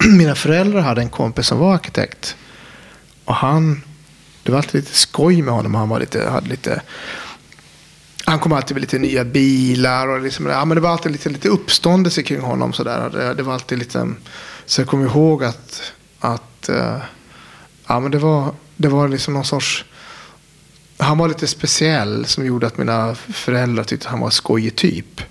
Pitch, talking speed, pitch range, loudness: 140 Hz, 185 wpm, 125-155 Hz, -17 LUFS